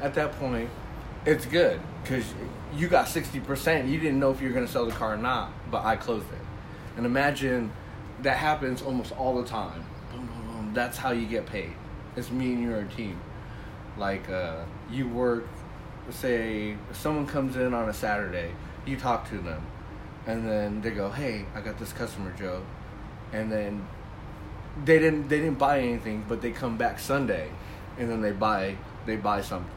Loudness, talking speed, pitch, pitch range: -29 LUFS, 190 wpm, 115 Hz, 105-130 Hz